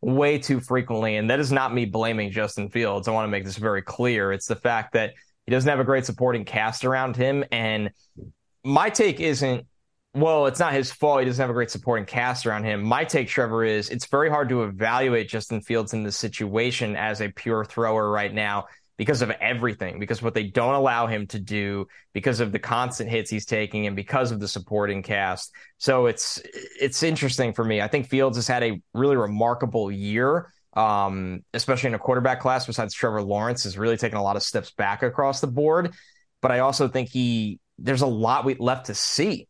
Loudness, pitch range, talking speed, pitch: -24 LUFS, 105-130 Hz, 215 wpm, 115 Hz